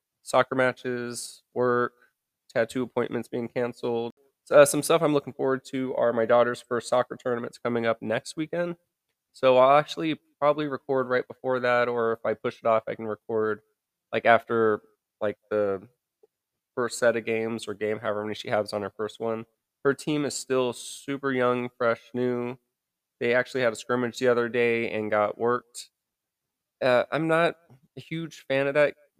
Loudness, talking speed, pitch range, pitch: -26 LUFS, 175 wpm, 115-135 Hz, 125 Hz